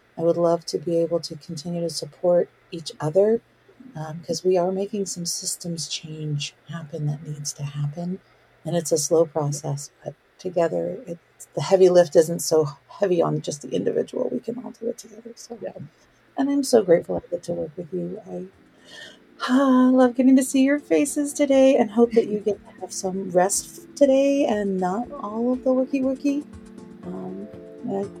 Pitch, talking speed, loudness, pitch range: 180 Hz, 185 wpm, -22 LUFS, 165-230 Hz